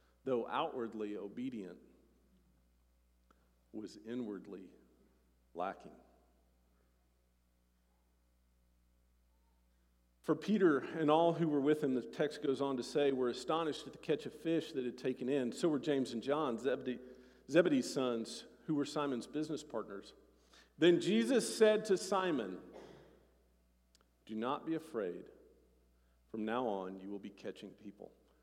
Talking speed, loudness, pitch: 130 wpm, -36 LUFS, 120 Hz